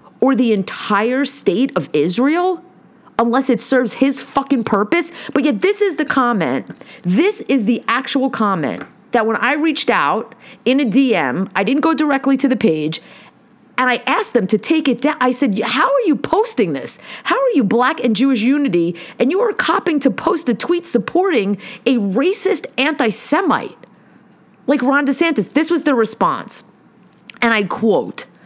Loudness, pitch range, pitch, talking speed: -16 LUFS, 225-295 Hz, 255 Hz, 175 wpm